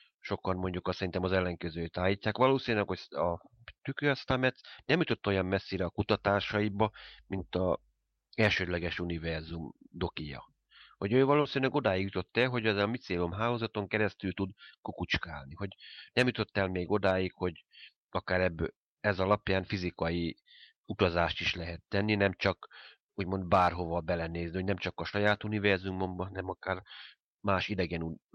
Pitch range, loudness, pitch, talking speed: 90-105 Hz, -32 LUFS, 95 Hz, 140 wpm